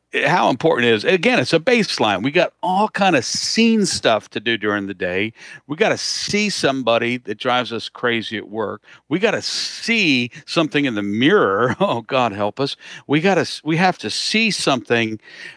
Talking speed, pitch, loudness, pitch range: 195 wpm, 125 Hz, -18 LUFS, 115-170 Hz